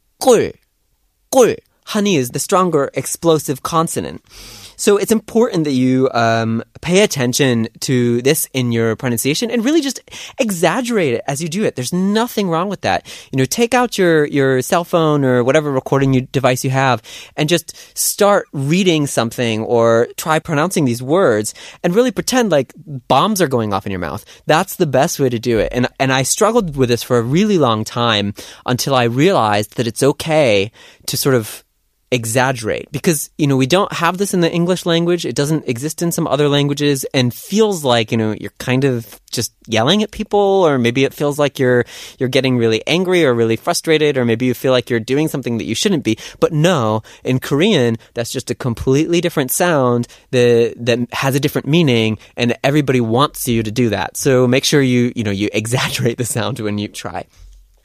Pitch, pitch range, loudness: 135 Hz, 120-170 Hz, -16 LUFS